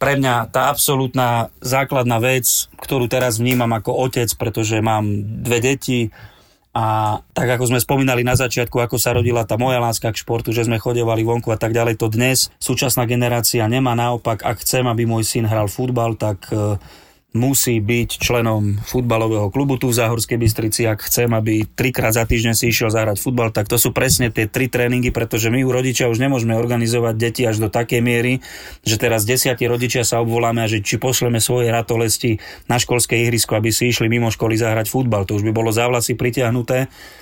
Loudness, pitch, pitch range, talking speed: -17 LUFS, 120 Hz, 115-125 Hz, 190 wpm